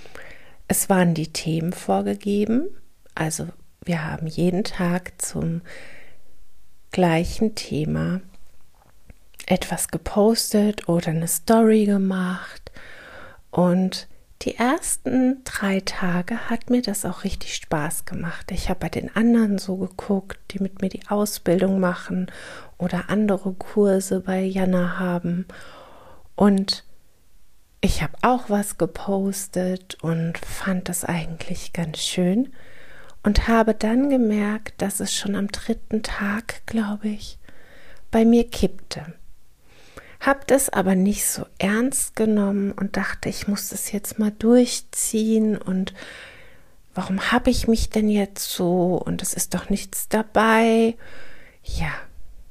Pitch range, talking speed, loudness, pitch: 180-220 Hz, 120 wpm, -22 LUFS, 195 Hz